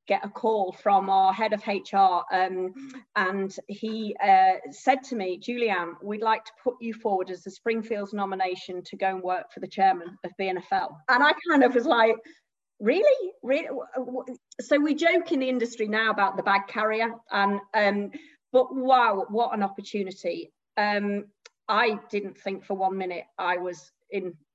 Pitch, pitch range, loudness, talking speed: 205 Hz, 190-240 Hz, -26 LUFS, 175 wpm